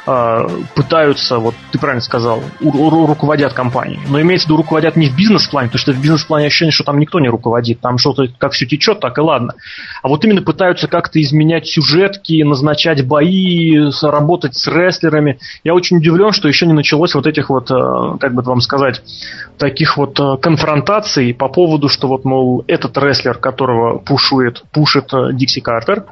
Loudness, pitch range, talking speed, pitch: -12 LUFS, 135-160 Hz, 175 wpm, 150 Hz